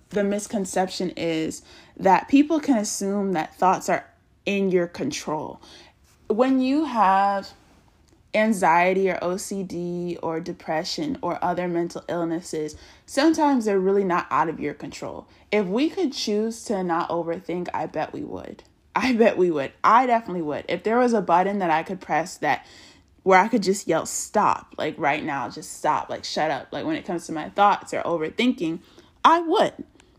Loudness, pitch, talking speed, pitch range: -23 LUFS, 195 Hz, 170 wpm, 175-235 Hz